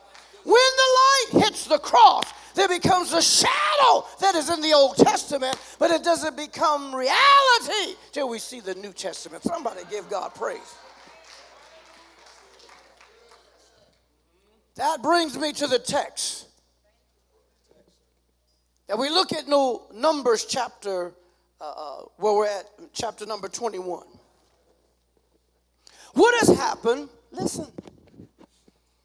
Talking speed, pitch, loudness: 115 wpm, 270 Hz, -21 LUFS